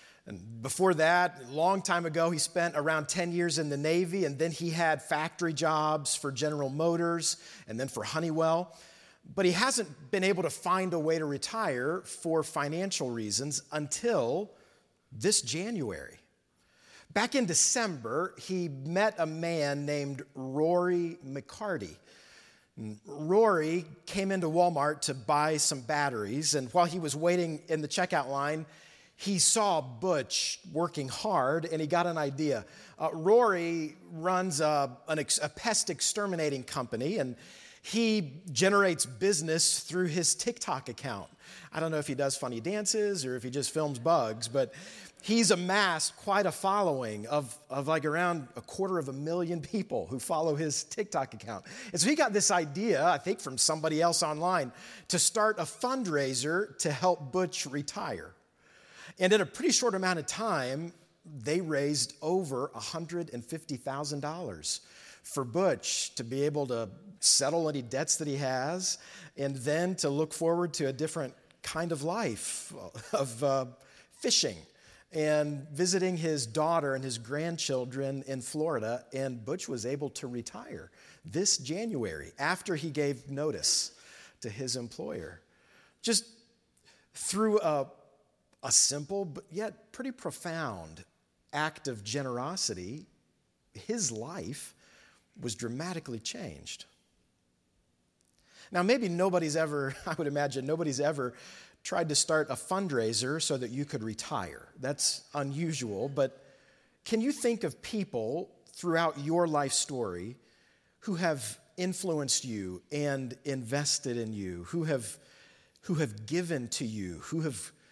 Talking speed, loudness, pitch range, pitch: 145 wpm, -31 LUFS, 140-180 Hz, 160 Hz